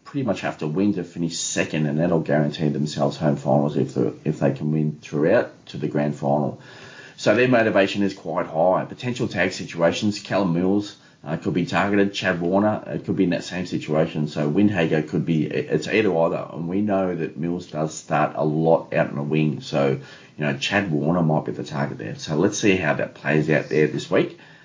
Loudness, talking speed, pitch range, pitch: -22 LUFS, 215 wpm, 75-95 Hz, 80 Hz